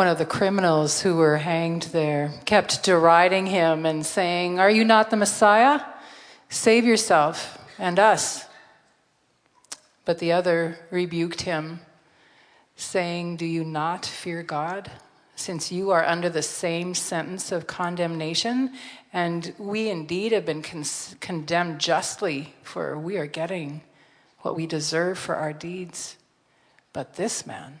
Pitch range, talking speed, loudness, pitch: 160-185 Hz, 135 wpm, -23 LUFS, 170 Hz